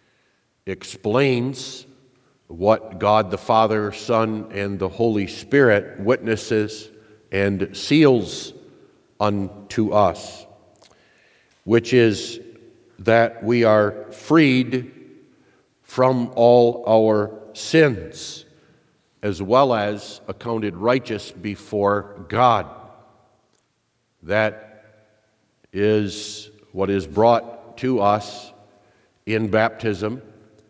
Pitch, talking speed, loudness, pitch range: 110 Hz, 80 wpm, -20 LUFS, 105-125 Hz